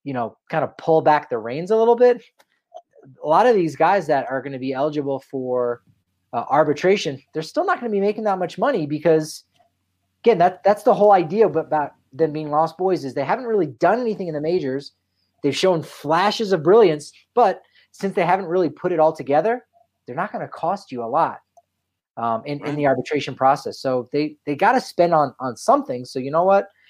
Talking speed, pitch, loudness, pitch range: 215 wpm, 155 Hz, -20 LUFS, 135-195 Hz